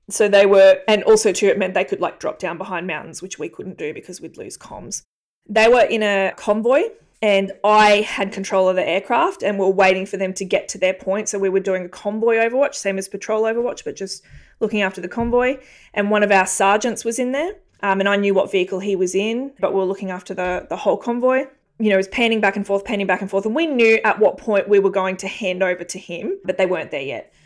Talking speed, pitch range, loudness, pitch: 260 wpm, 190-225 Hz, -18 LUFS, 200 Hz